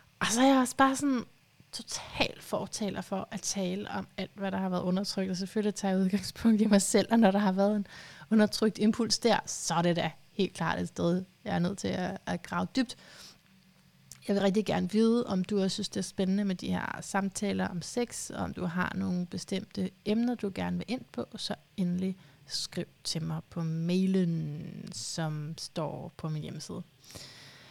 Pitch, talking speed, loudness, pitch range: 190 Hz, 200 wpm, -31 LUFS, 175-210 Hz